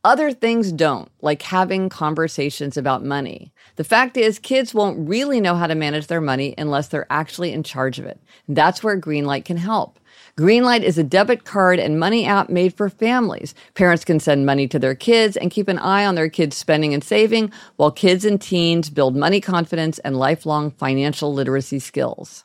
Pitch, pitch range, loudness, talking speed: 165 Hz, 145-200 Hz, -19 LUFS, 195 wpm